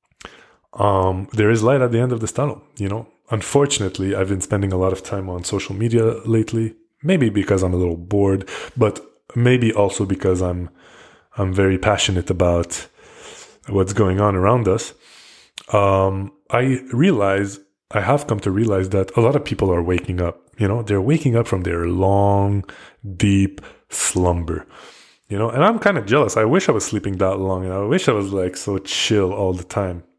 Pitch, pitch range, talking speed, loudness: 100 Hz, 95-115 Hz, 190 wpm, -19 LUFS